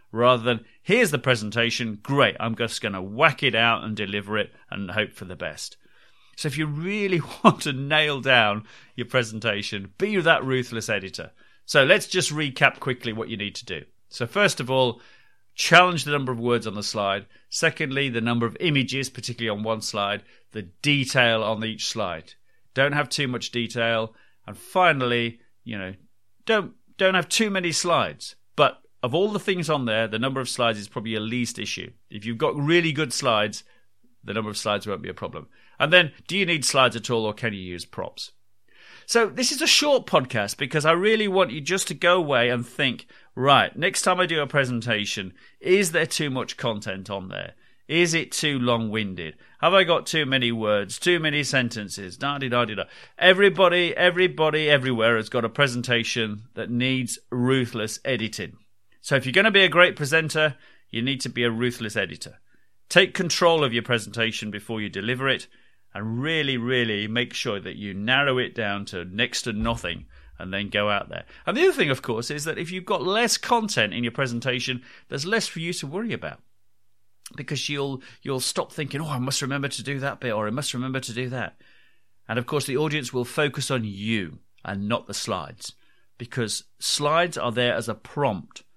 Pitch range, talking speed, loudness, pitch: 110-155 Hz, 195 wpm, -23 LUFS, 125 Hz